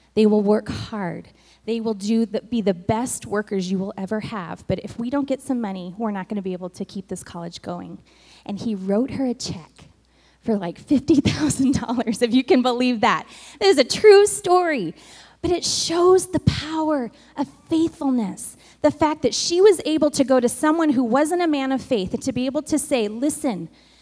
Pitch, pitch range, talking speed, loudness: 250 Hz, 210-300 Hz, 205 wpm, -21 LUFS